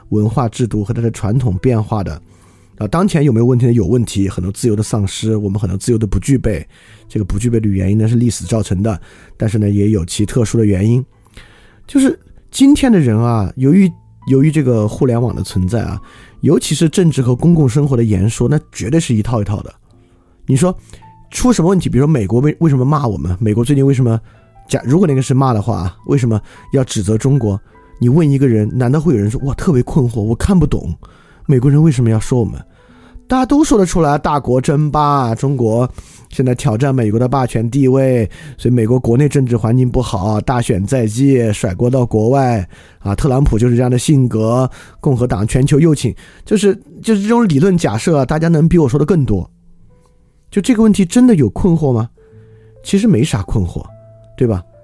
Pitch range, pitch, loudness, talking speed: 110-140 Hz, 120 Hz, -14 LUFS, 310 characters per minute